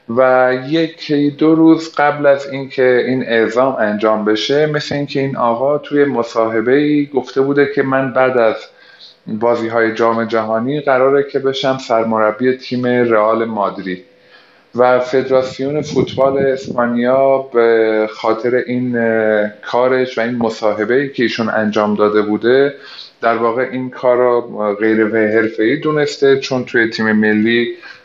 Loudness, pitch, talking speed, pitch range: -14 LUFS, 125 Hz, 140 wpm, 115-135 Hz